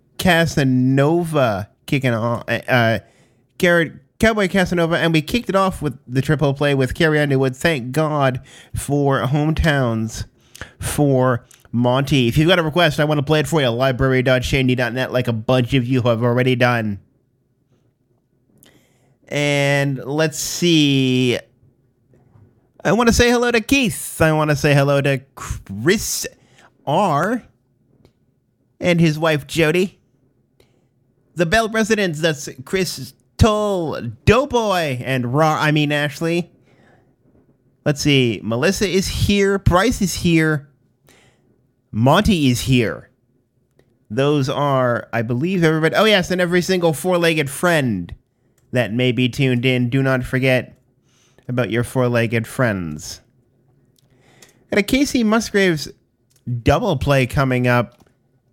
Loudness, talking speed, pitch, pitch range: -18 LUFS, 125 wpm, 135 Hz, 125-160 Hz